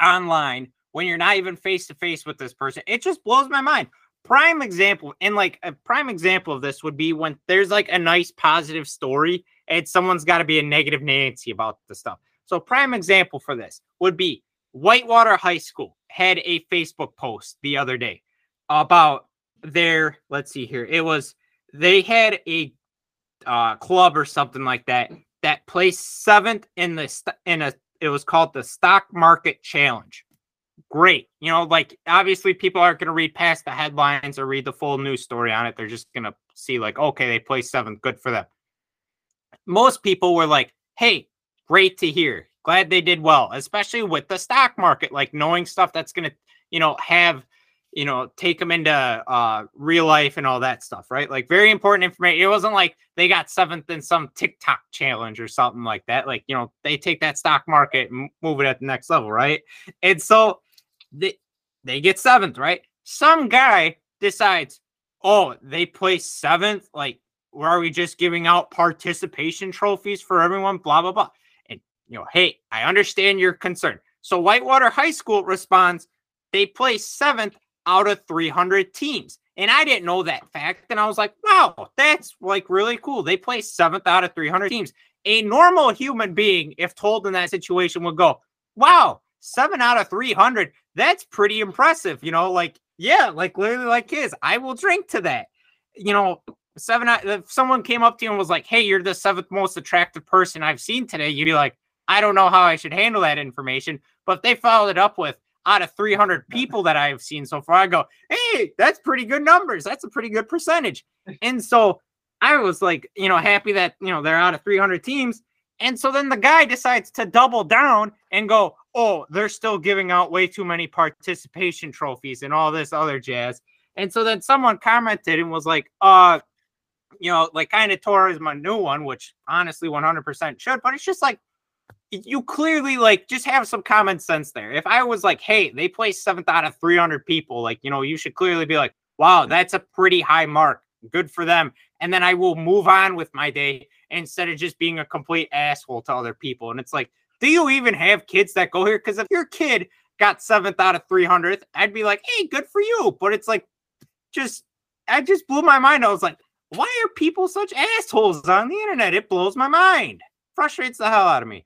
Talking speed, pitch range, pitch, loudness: 205 wpm, 160-225 Hz, 185 Hz, -18 LUFS